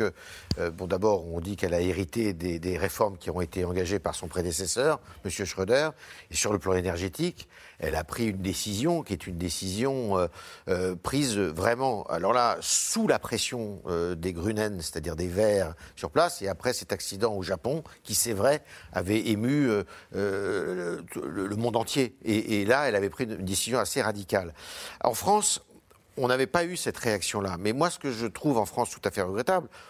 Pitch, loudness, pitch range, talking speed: 100 Hz, -28 LUFS, 90-120 Hz, 200 wpm